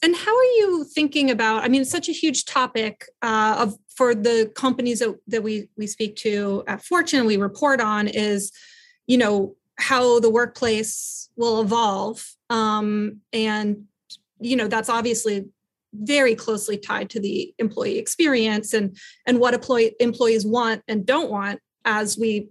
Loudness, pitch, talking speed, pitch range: -21 LUFS, 225 Hz, 165 wpm, 215-255 Hz